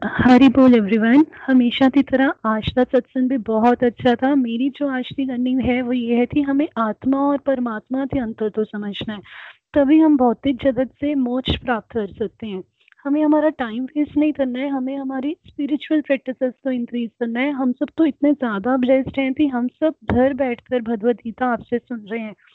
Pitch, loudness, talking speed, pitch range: 260 Hz, -19 LUFS, 195 wpm, 240-280 Hz